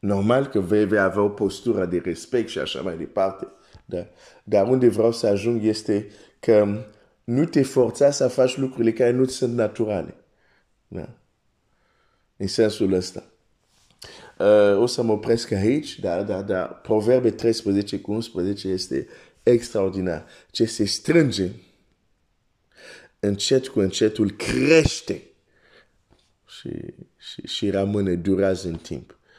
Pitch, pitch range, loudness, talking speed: 105 Hz, 95-120 Hz, -22 LUFS, 130 wpm